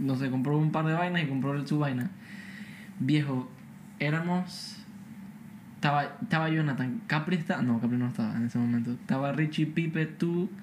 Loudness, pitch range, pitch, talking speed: -29 LUFS, 140-195 Hz, 160 Hz, 165 wpm